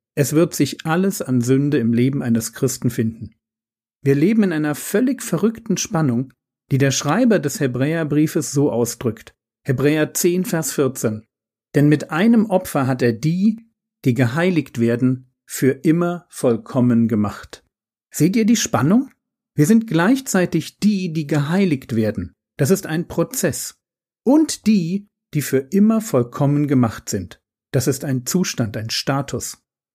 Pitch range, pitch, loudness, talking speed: 125-185 Hz, 145 Hz, -19 LUFS, 145 wpm